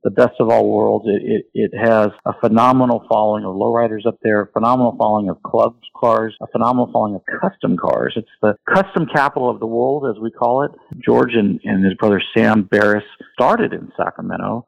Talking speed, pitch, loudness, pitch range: 200 wpm, 115 Hz, -17 LUFS, 105-120 Hz